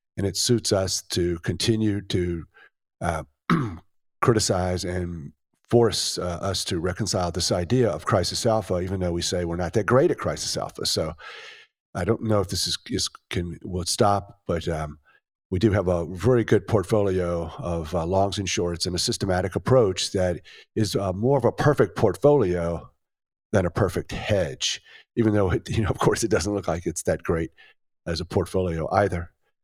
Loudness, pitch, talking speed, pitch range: -24 LUFS, 95 Hz, 180 wpm, 90-110 Hz